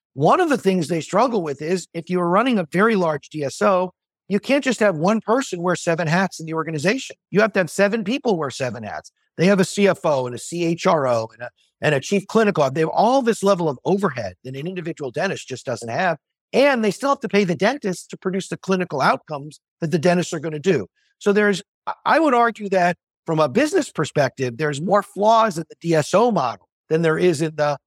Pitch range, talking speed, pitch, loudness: 160-205 Hz, 225 wpm, 180 Hz, -20 LUFS